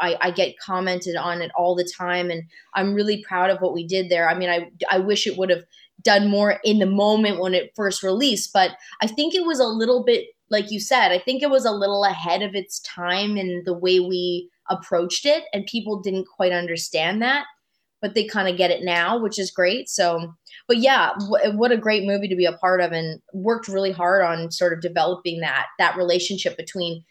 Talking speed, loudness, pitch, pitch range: 230 wpm, -21 LUFS, 190 Hz, 175-210 Hz